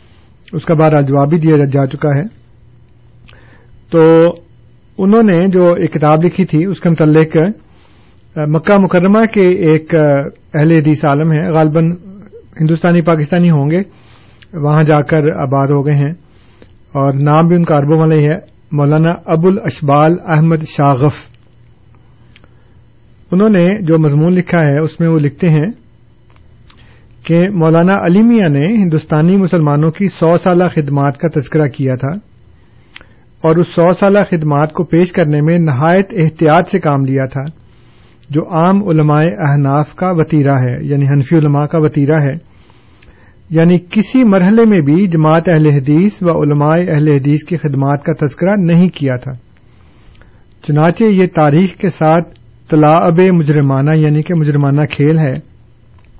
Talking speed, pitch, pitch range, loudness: 145 wpm, 155 Hz, 135-170 Hz, -11 LUFS